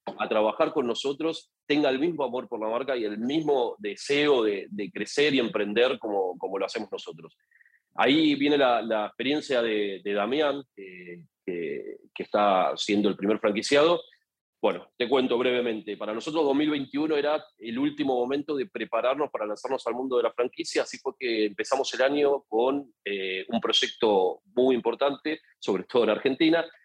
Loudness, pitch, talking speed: -26 LUFS, 145 Hz, 170 wpm